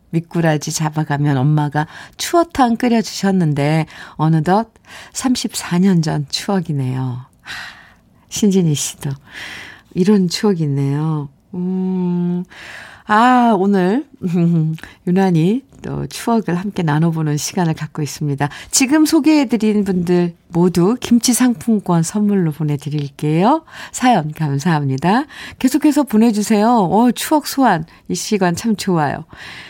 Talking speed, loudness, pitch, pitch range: 250 characters per minute, -16 LUFS, 180 Hz, 155-225 Hz